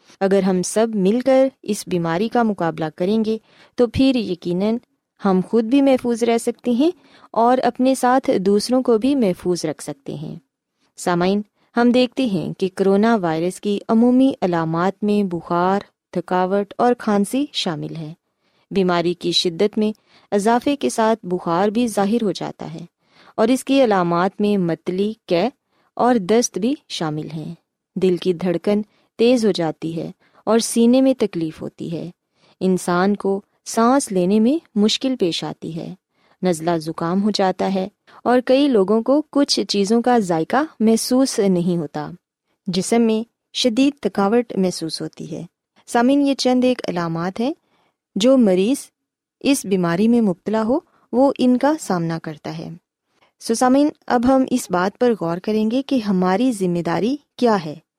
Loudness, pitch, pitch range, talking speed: -19 LUFS, 210 Hz, 180-245 Hz, 155 wpm